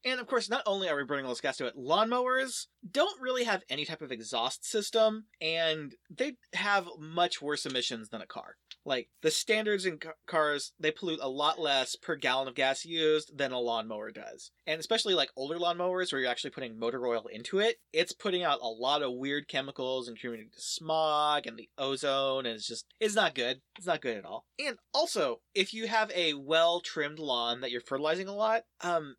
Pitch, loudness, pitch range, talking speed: 155 Hz, -31 LUFS, 135-205 Hz, 215 wpm